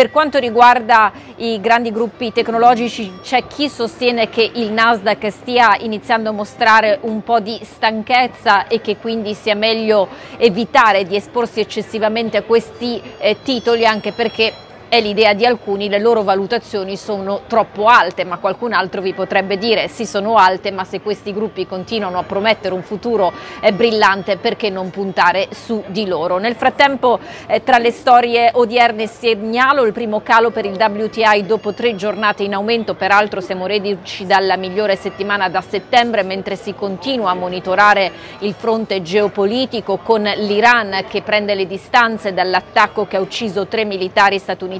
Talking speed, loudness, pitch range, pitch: 160 wpm, -15 LUFS, 200-230 Hz, 215 Hz